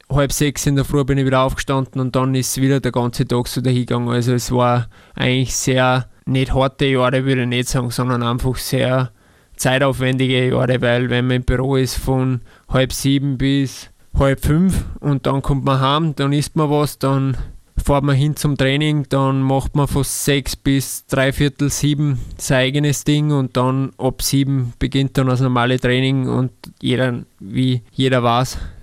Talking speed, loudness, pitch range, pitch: 185 wpm, -18 LUFS, 125-140 Hz, 130 Hz